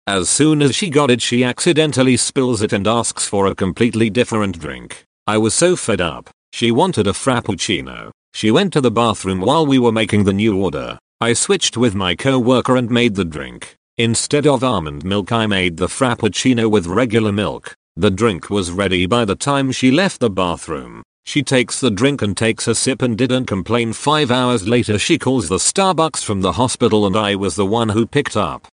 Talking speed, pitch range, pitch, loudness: 205 wpm, 105-130 Hz, 115 Hz, -16 LUFS